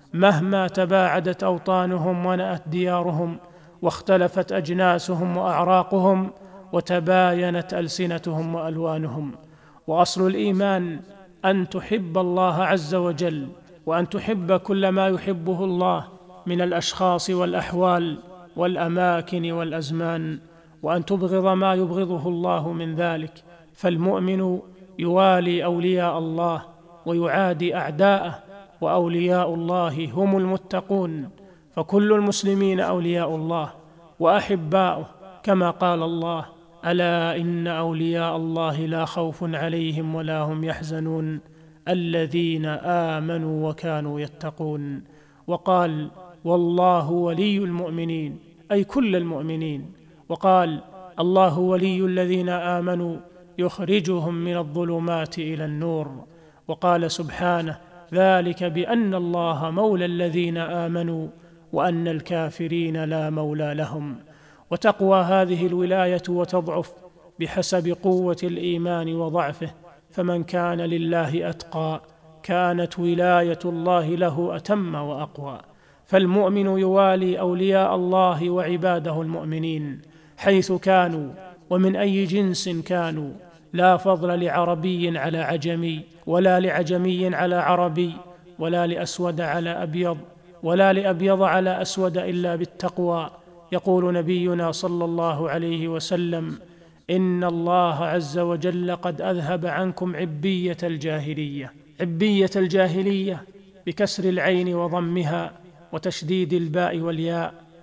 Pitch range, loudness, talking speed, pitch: 165-185 Hz, -23 LUFS, 95 wpm, 175 Hz